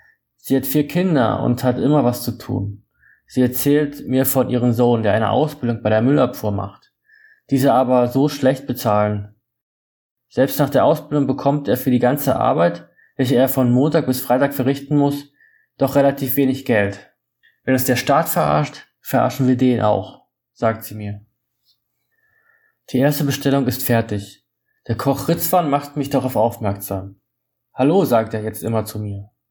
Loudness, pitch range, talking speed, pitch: -18 LUFS, 115-140 Hz, 165 wpm, 130 Hz